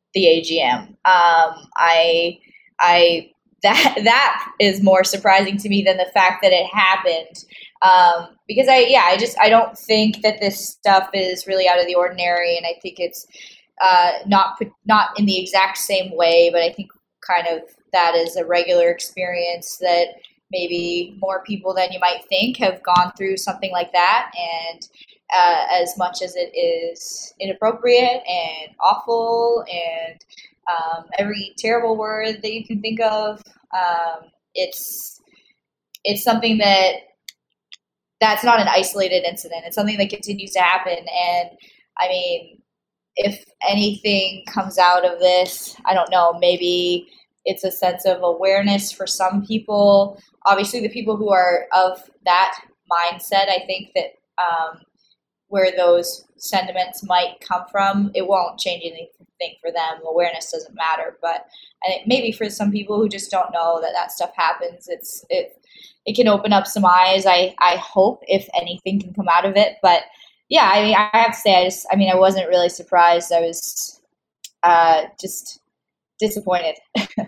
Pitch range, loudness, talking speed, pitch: 175-210 Hz, -18 LUFS, 160 wpm, 190 Hz